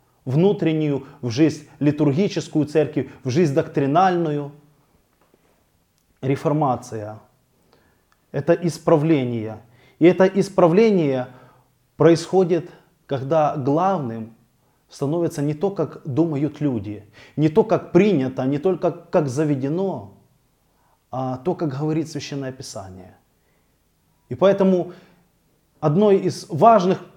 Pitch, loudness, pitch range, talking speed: 150 Hz, -20 LUFS, 130-170 Hz, 95 wpm